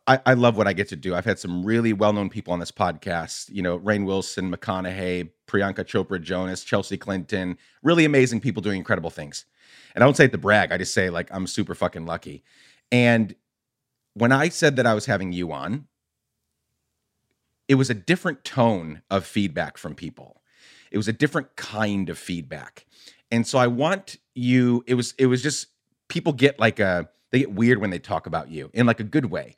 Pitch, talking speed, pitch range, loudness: 105 Hz, 205 wpm, 95-125 Hz, -23 LUFS